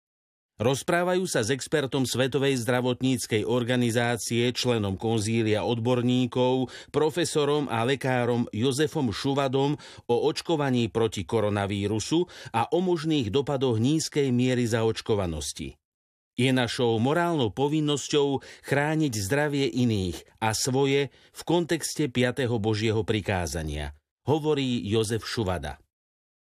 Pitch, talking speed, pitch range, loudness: 125 Hz, 95 wpm, 110-140 Hz, -26 LUFS